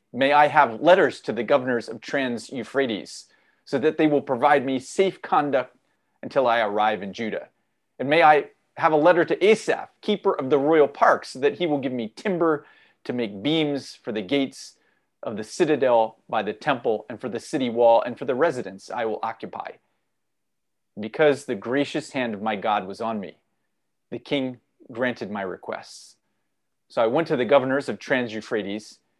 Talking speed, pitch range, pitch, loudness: 190 wpm, 115-150 Hz, 135 Hz, -23 LUFS